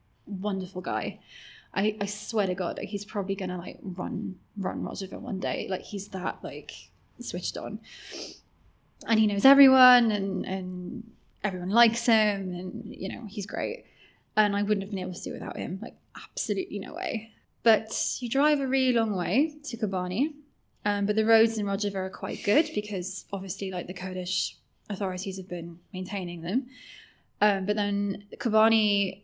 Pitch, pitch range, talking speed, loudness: 205 Hz, 190-225 Hz, 170 wpm, -27 LUFS